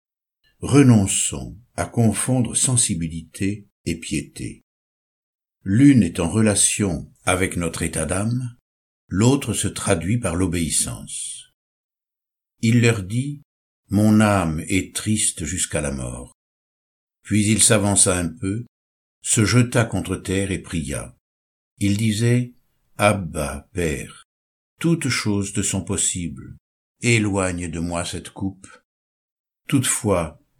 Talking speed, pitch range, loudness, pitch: 110 wpm, 85-110 Hz, -20 LUFS, 95 Hz